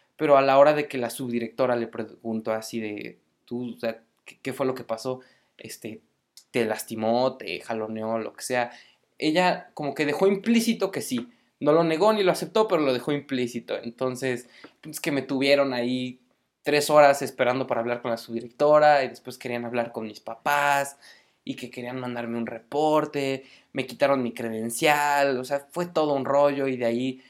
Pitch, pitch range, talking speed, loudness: 130 Hz, 120-145 Hz, 190 wpm, -25 LUFS